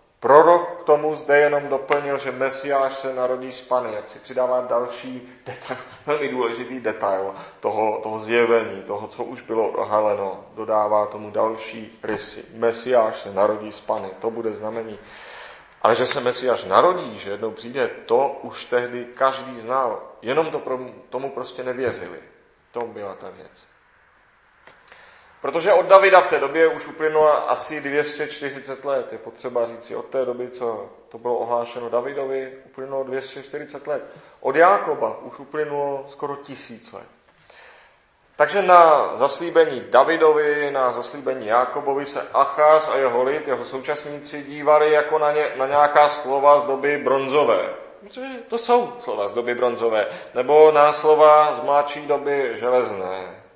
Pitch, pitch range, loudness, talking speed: 135 Hz, 120-150 Hz, -20 LUFS, 150 wpm